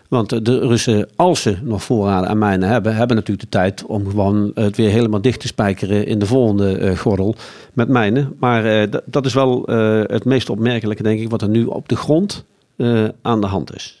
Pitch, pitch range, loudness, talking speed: 110 Hz, 105-120 Hz, -17 LUFS, 200 wpm